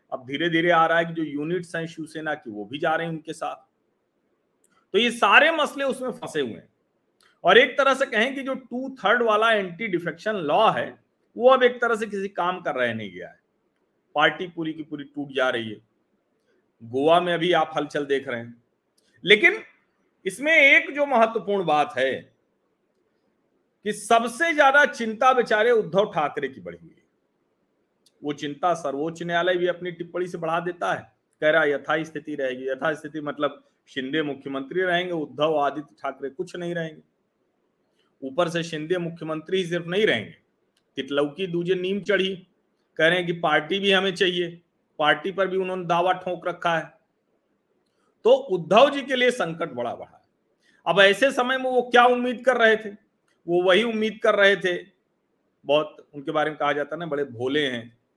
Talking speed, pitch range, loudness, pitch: 180 wpm, 150-215 Hz, -22 LUFS, 175 Hz